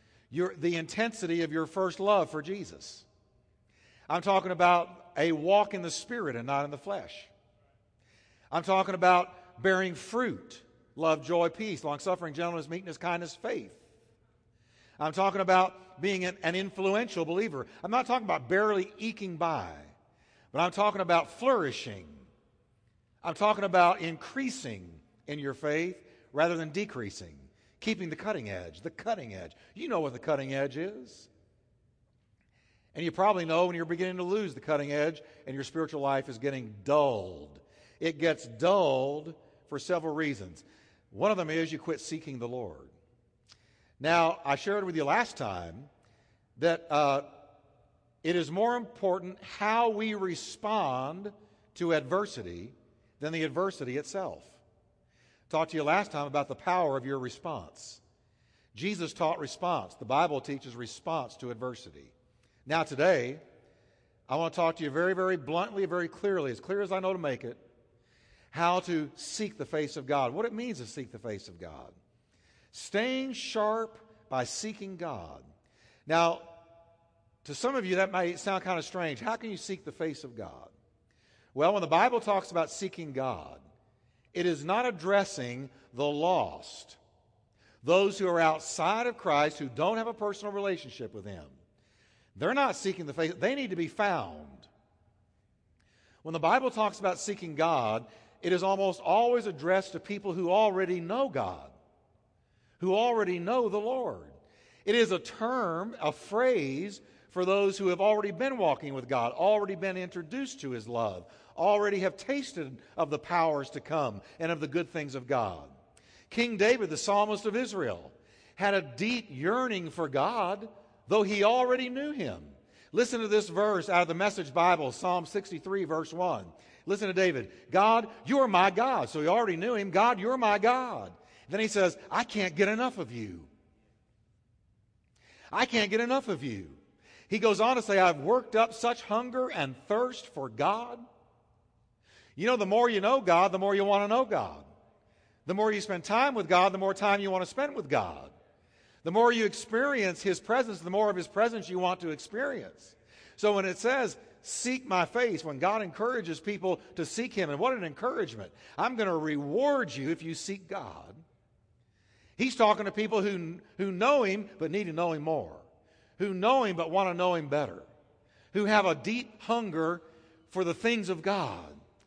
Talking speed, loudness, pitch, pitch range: 170 wpm, -30 LUFS, 170 Hz, 135-205 Hz